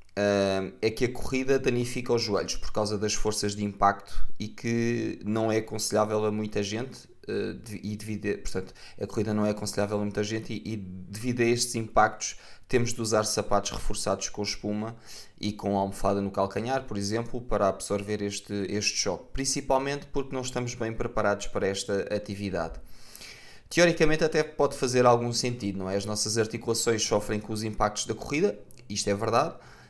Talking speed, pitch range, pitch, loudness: 180 wpm, 100-120 Hz, 105 Hz, -28 LUFS